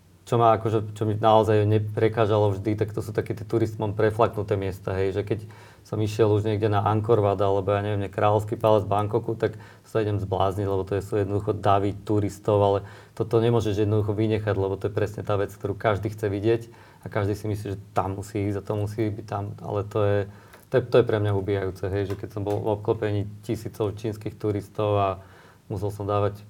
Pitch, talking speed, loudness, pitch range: 105 Hz, 220 wpm, -25 LUFS, 100-110 Hz